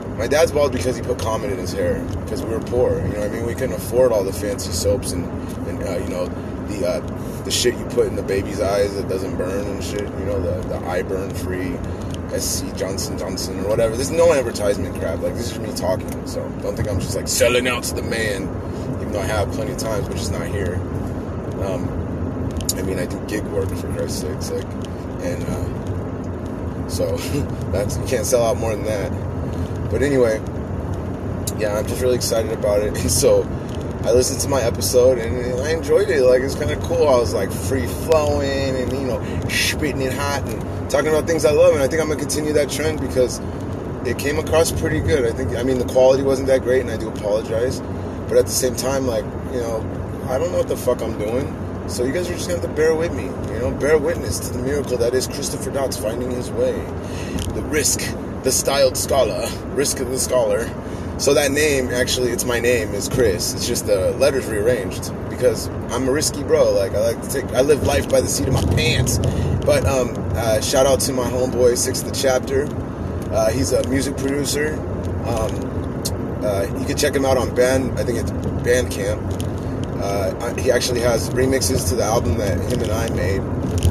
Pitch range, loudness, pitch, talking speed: 90-125 Hz, -20 LUFS, 105 Hz, 215 wpm